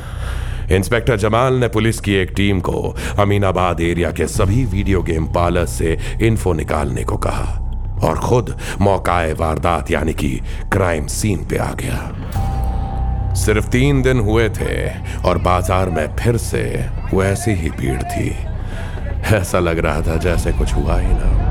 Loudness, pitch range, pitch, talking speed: -18 LUFS, 85-105 Hz, 95 Hz, 150 wpm